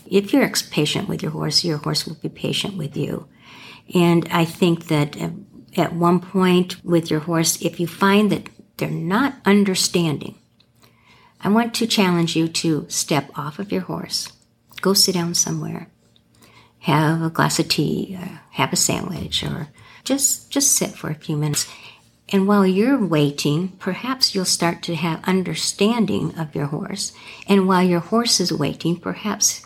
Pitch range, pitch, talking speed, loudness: 160-195 Hz, 175 Hz, 165 wpm, -20 LUFS